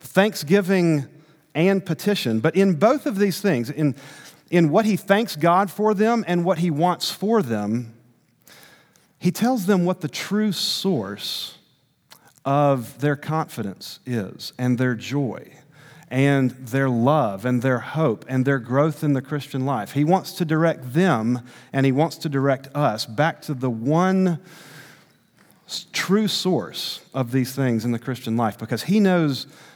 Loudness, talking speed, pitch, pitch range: -22 LUFS, 155 wpm, 150 Hz, 130-180 Hz